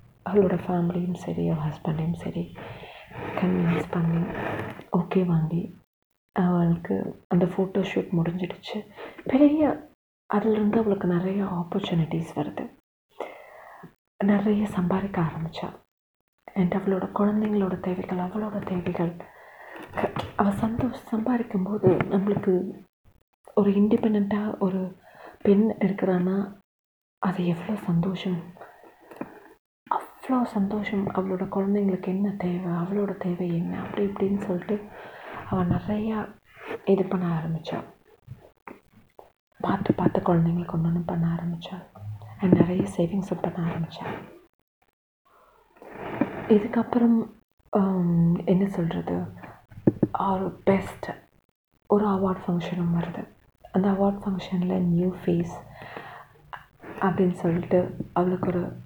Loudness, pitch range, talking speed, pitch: -26 LUFS, 175-200 Hz, 85 wpm, 185 Hz